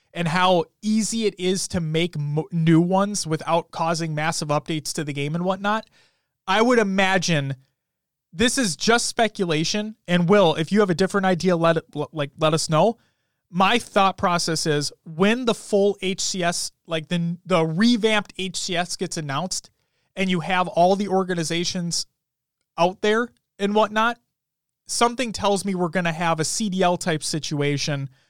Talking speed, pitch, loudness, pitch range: 160 wpm, 175 Hz, -22 LUFS, 160-200 Hz